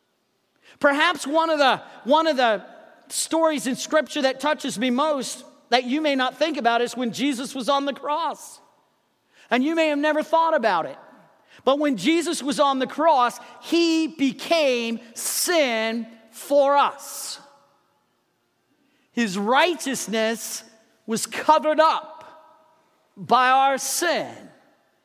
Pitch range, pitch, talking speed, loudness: 245-315 Hz, 280 Hz, 130 wpm, -22 LUFS